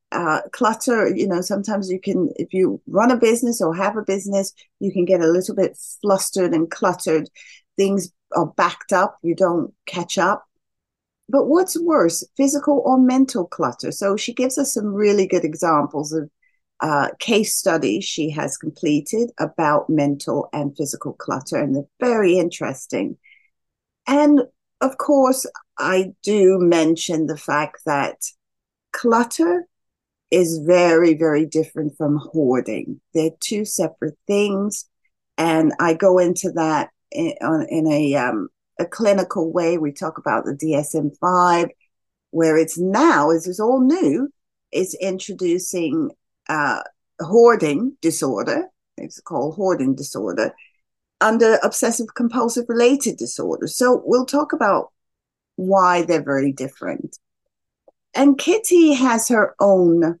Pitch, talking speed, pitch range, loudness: 190 Hz, 135 wpm, 165-245 Hz, -19 LUFS